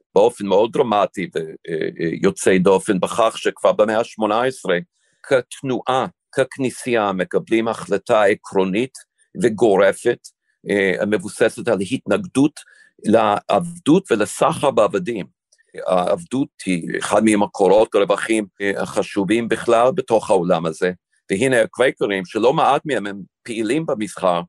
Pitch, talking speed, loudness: 115 Hz, 95 wpm, -19 LUFS